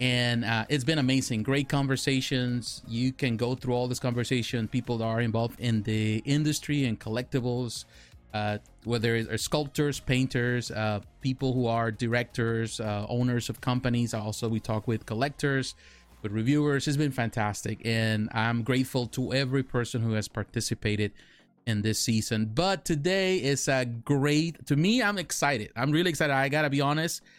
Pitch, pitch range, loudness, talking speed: 125 Hz, 115-140 Hz, -28 LUFS, 165 wpm